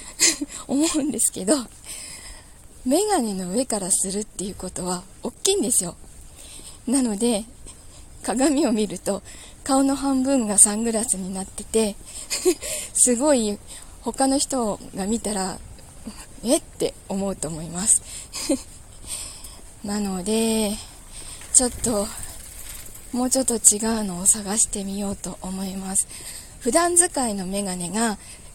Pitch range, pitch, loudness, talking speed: 190-260 Hz, 215 Hz, -22 LUFS, 230 characters per minute